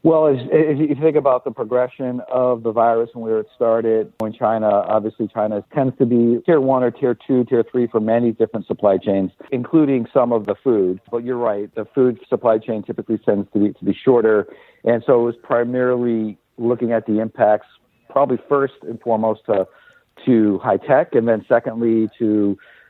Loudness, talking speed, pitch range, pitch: -18 LUFS, 190 wpm, 110-130 Hz, 115 Hz